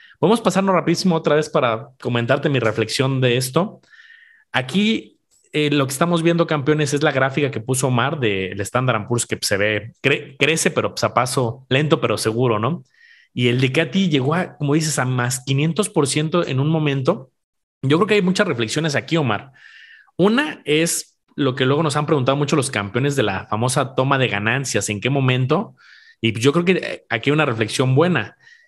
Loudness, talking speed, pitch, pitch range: -19 LUFS, 195 wpm, 140 Hz, 125-160 Hz